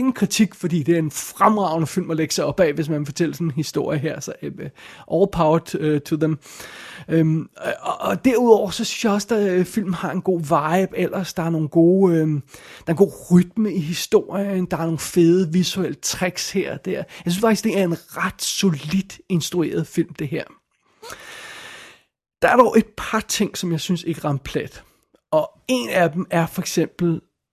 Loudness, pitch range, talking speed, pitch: -20 LUFS, 165-200 Hz, 195 wpm, 180 Hz